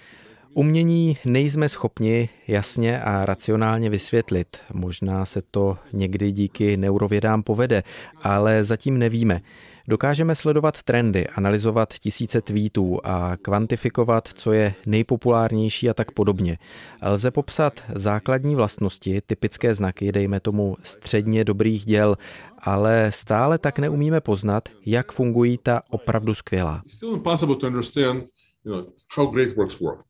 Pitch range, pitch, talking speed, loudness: 100-125 Hz, 110 Hz, 105 wpm, -22 LUFS